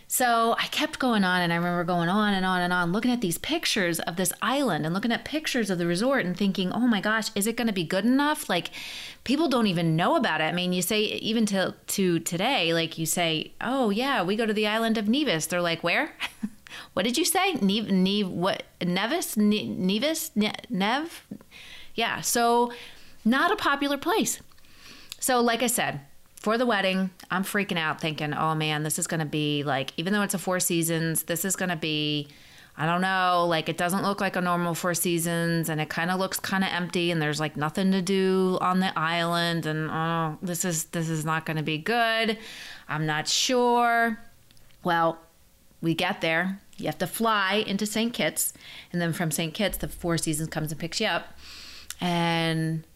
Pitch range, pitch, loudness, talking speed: 170-225 Hz, 185 Hz, -26 LUFS, 210 wpm